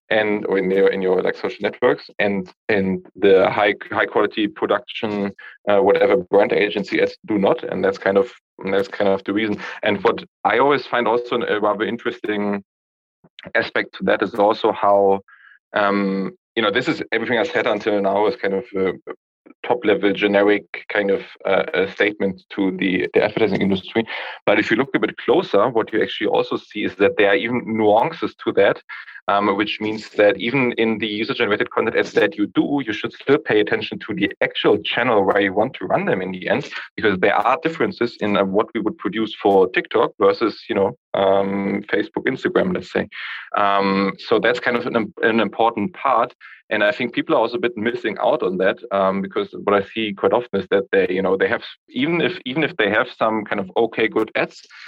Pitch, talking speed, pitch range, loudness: 105 Hz, 205 wpm, 100-120 Hz, -19 LUFS